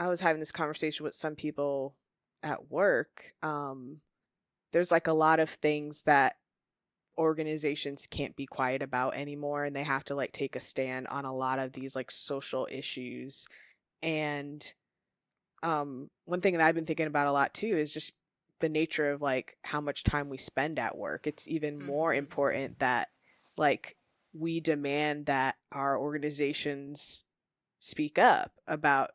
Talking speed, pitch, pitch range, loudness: 165 wpm, 145 Hz, 140-155 Hz, -32 LUFS